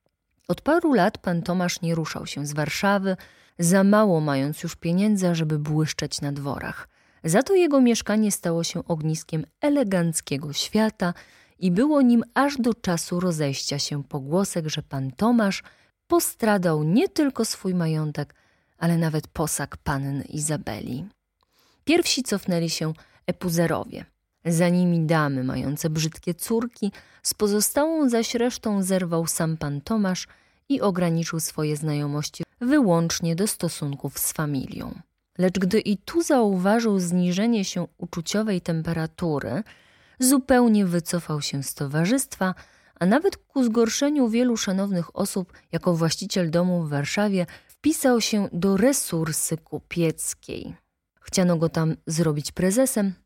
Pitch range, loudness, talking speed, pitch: 160-215 Hz, -24 LUFS, 125 wpm, 175 Hz